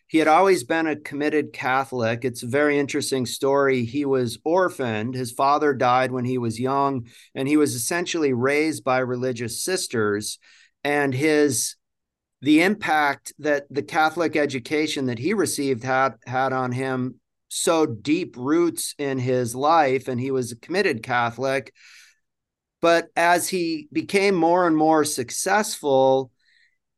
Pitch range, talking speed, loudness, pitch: 130-155 Hz, 145 wpm, -22 LUFS, 140 Hz